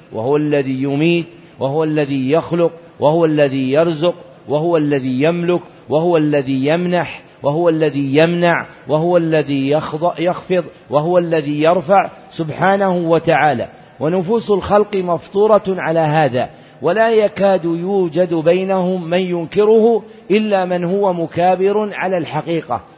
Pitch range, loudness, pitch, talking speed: 155-185 Hz, -16 LUFS, 170 Hz, 110 wpm